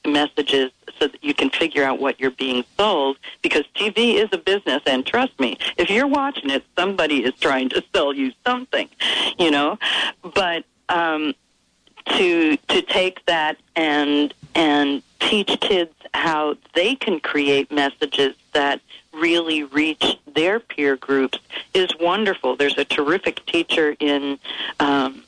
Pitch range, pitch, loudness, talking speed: 140-195 Hz, 150 Hz, -20 LUFS, 145 wpm